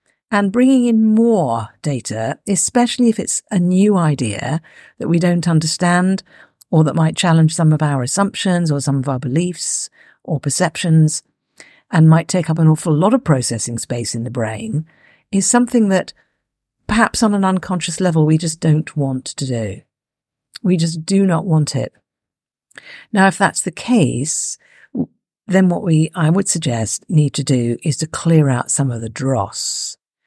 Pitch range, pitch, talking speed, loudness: 140-190 Hz, 160 Hz, 170 wpm, -16 LUFS